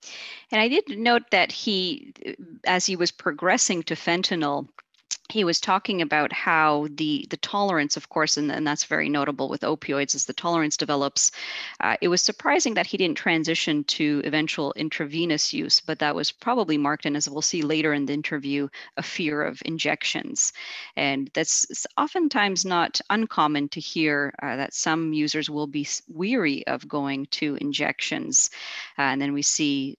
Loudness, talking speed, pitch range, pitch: -24 LUFS, 170 wpm, 145-185 Hz, 155 Hz